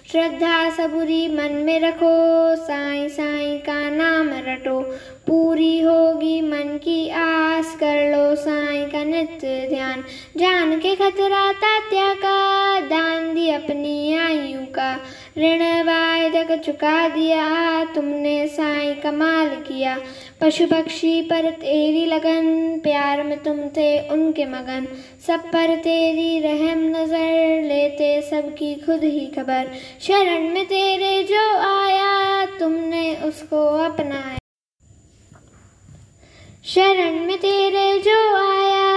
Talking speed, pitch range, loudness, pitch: 110 wpm, 295-330 Hz, -19 LUFS, 320 Hz